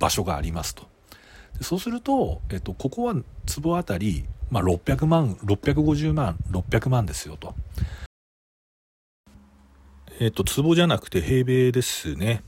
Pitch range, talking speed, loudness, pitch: 85-140 Hz, 260 characters per minute, -24 LUFS, 105 Hz